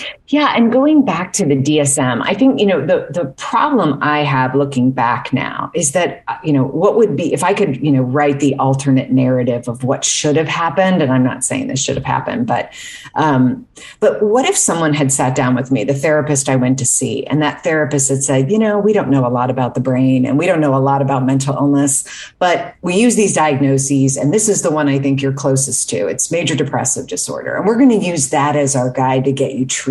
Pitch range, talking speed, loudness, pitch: 130-170 Hz, 245 wpm, -14 LUFS, 140 Hz